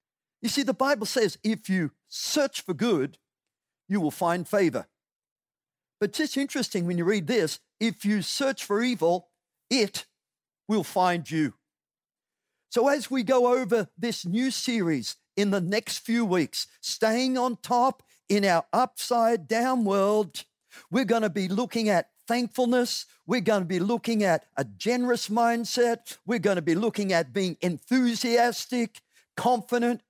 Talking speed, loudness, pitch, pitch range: 155 wpm, -26 LUFS, 225 Hz, 195-245 Hz